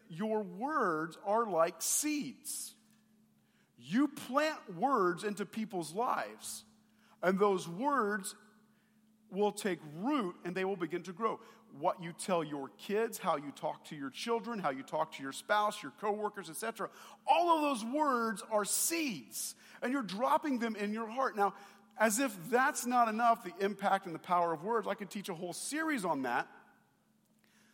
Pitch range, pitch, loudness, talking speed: 185-235 Hz, 210 Hz, -35 LUFS, 165 wpm